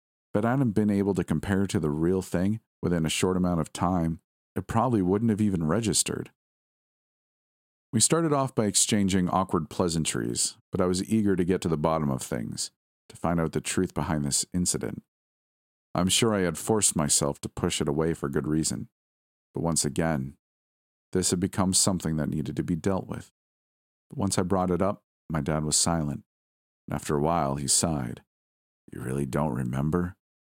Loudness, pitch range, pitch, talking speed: -26 LUFS, 70-95 Hz, 85 Hz, 185 wpm